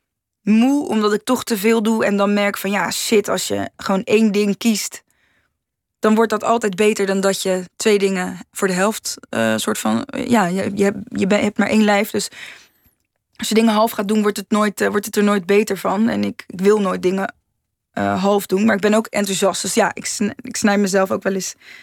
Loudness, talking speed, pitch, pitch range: -18 LUFS, 235 wpm, 205 Hz, 195-220 Hz